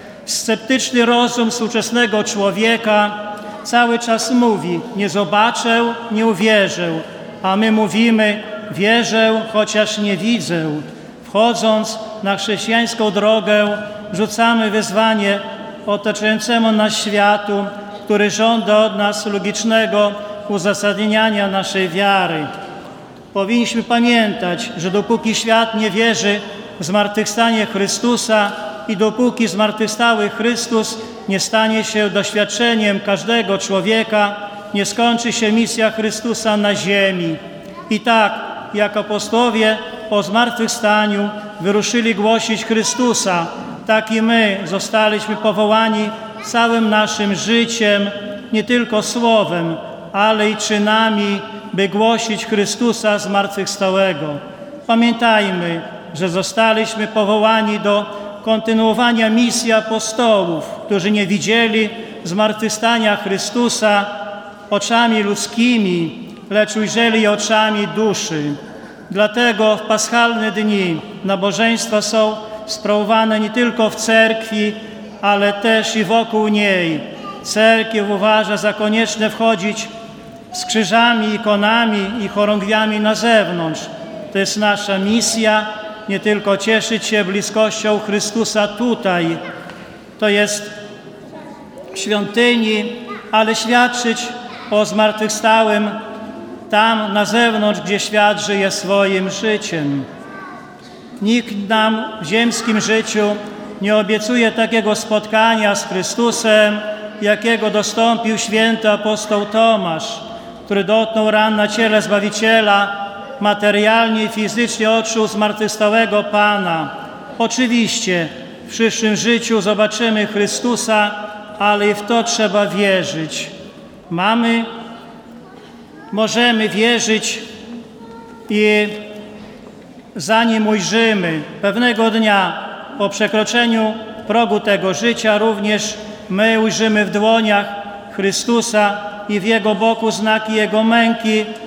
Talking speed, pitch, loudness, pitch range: 95 wpm, 215 Hz, -15 LUFS, 205-225 Hz